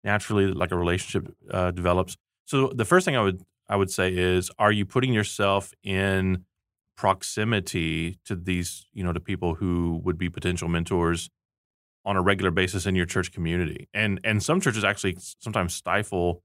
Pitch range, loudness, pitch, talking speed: 90-100 Hz, -25 LUFS, 95 Hz, 175 wpm